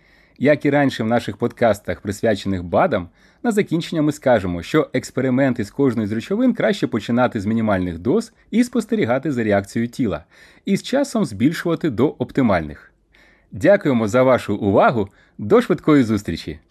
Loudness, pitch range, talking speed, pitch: -19 LUFS, 110-170 Hz, 145 wpm, 130 Hz